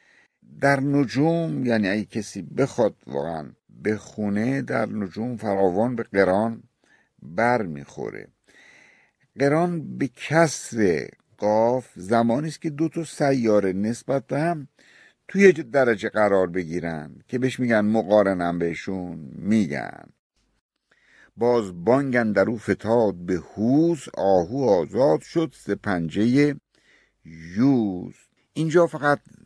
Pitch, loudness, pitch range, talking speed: 115 Hz, -23 LUFS, 95-145 Hz, 110 wpm